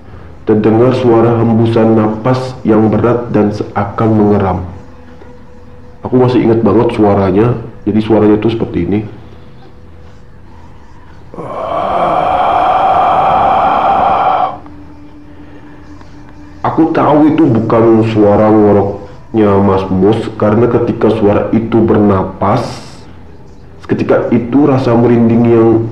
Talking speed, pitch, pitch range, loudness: 85 wpm, 110 Hz, 100-120 Hz, -10 LUFS